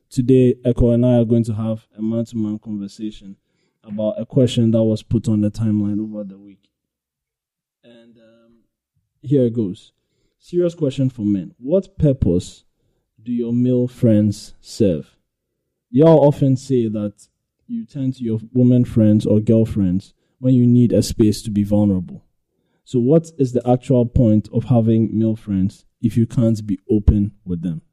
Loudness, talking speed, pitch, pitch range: -18 LUFS, 165 wpm, 115 Hz, 105-125 Hz